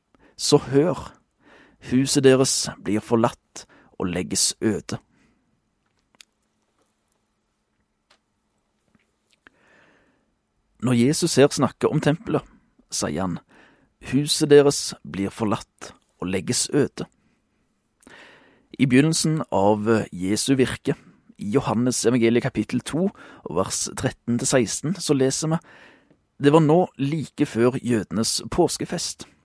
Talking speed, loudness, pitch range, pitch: 95 wpm, -22 LUFS, 120-150 Hz, 130 Hz